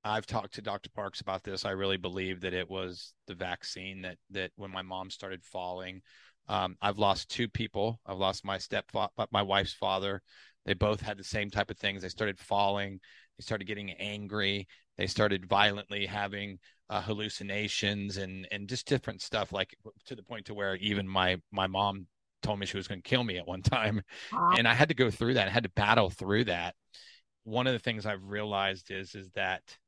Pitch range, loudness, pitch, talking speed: 95-105 Hz, -32 LUFS, 100 Hz, 205 wpm